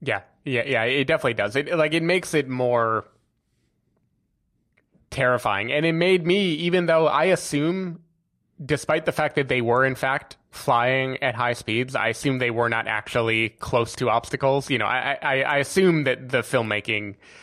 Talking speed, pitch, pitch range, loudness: 175 wpm, 135 Hz, 120-155 Hz, -22 LUFS